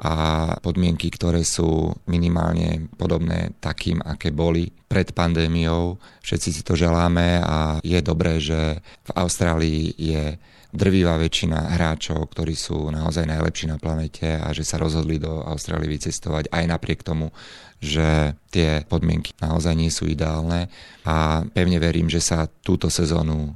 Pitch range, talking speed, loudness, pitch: 80-85 Hz, 140 wpm, -22 LUFS, 80 Hz